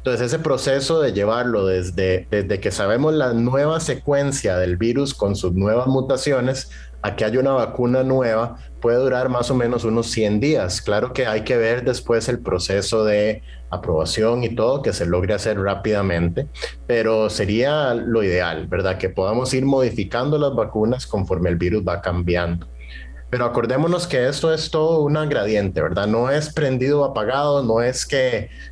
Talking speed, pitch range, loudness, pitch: 170 wpm, 95-130 Hz, -20 LUFS, 115 Hz